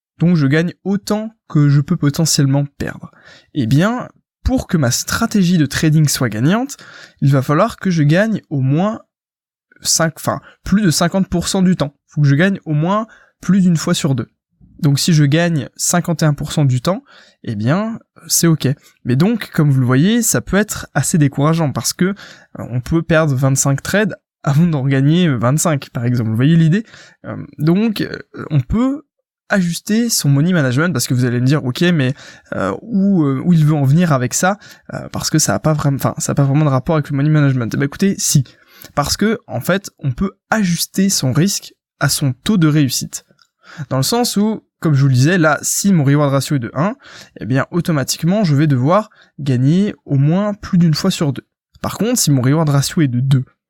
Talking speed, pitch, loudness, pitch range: 210 wpm, 155 Hz, -15 LUFS, 140-180 Hz